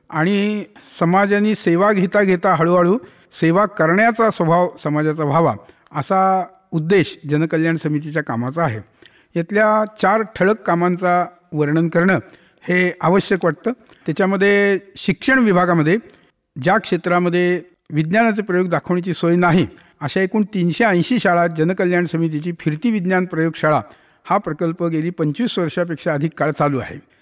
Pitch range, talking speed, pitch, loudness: 165-195 Hz, 120 wpm, 175 Hz, -18 LUFS